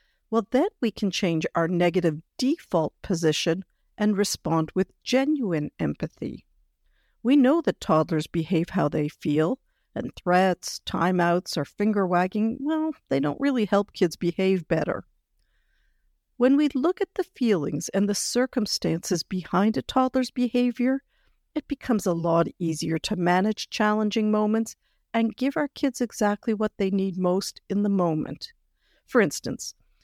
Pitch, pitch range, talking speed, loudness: 200 Hz, 175-245 Hz, 145 wpm, -25 LUFS